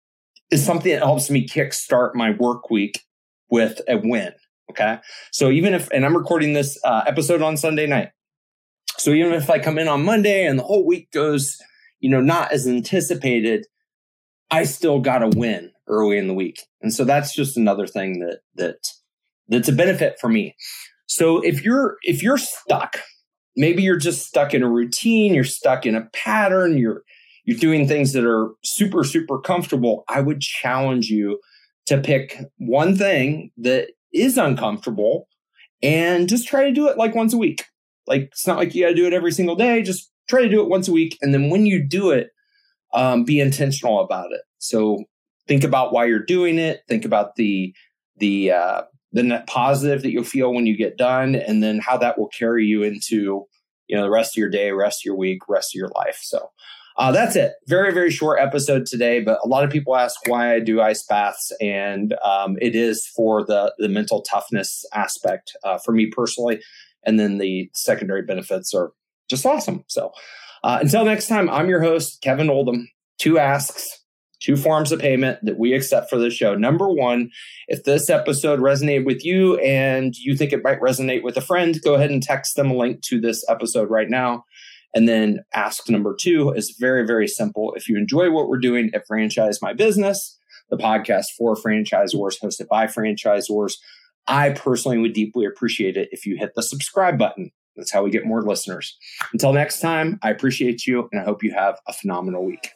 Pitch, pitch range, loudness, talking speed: 135 Hz, 115-170 Hz, -19 LUFS, 200 wpm